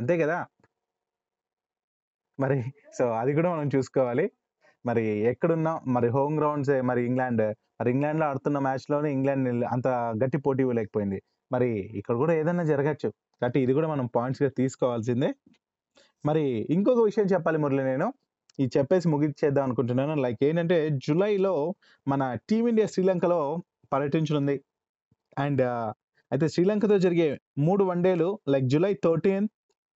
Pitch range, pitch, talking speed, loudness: 130-170 Hz, 140 Hz, 125 wpm, -26 LUFS